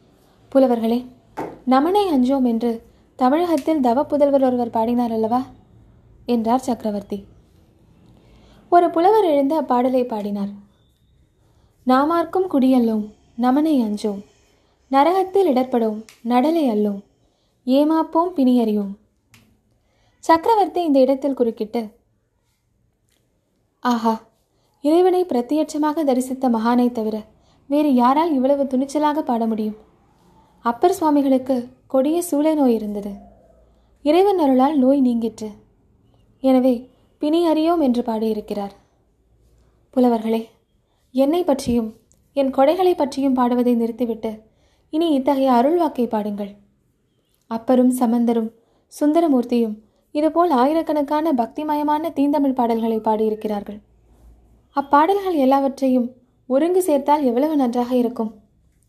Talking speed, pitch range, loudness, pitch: 90 wpm, 225-295 Hz, -19 LUFS, 255 Hz